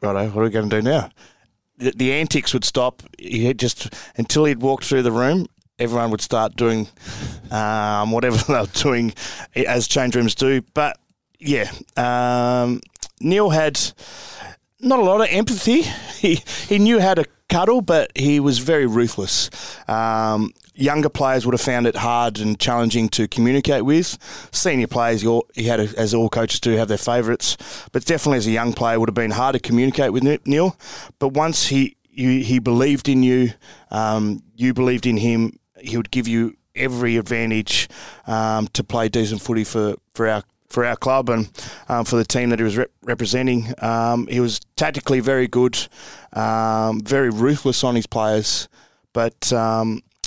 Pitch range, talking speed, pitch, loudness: 110-135 Hz, 175 wpm, 120 Hz, -19 LUFS